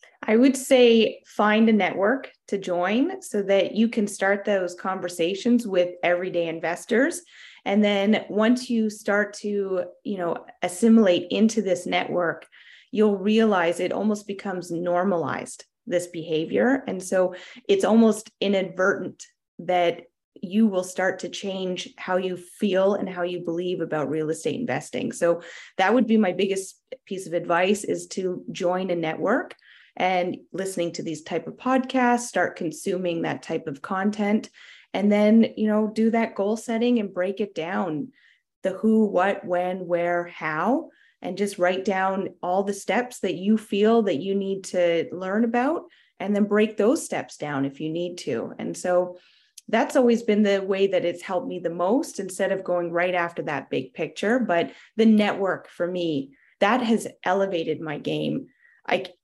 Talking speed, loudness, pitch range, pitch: 165 wpm, -24 LUFS, 180-220 Hz, 195 Hz